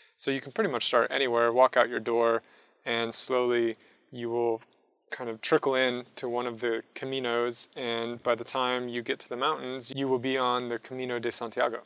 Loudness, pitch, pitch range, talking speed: -29 LUFS, 120 Hz, 115-130 Hz, 205 wpm